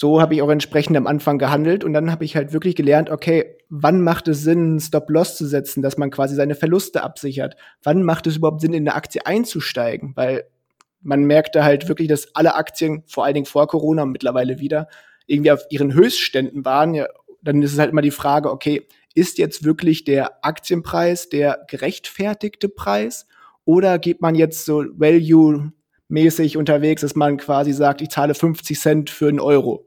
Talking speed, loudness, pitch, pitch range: 190 wpm, -18 LUFS, 155 Hz, 145-165 Hz